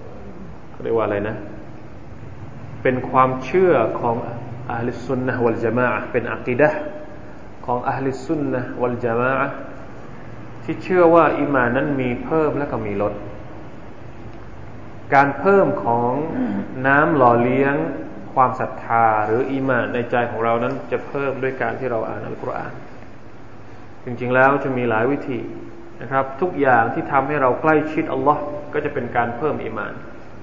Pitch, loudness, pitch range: 125 Hz, -20 LUFS, 115-135 Hz